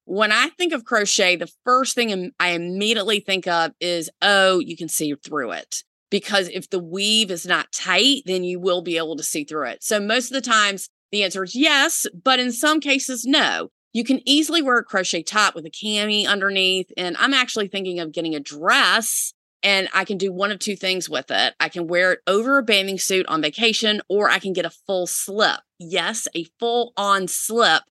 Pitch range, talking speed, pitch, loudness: 180-230 Hz, 215 wpm, 195 Hz, -20 LUFS